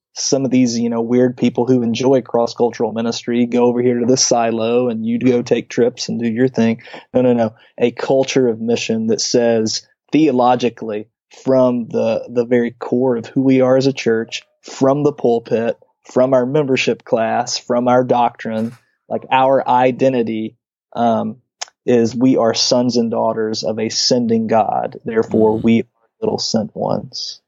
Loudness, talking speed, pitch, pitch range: -16 LUFS, 170 wpm, 120 Hz, 115-130 Hz